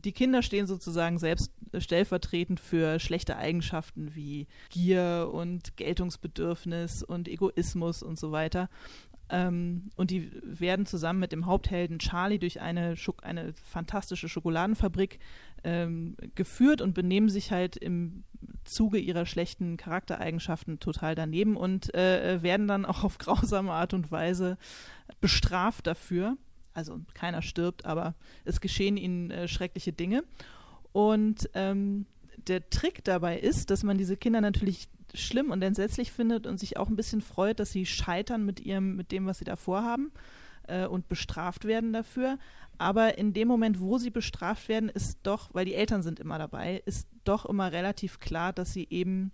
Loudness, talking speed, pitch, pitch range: -31 LUFS, 155 wpm, 185 Hz, 175-205 Hz